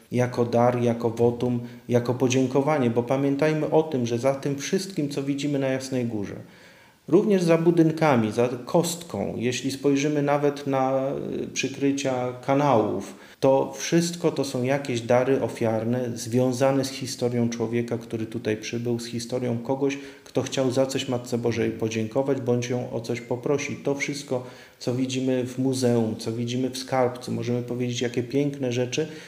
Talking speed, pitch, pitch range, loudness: 150 wpm, 125 Hz, 120-140 Hz, -25 LUFS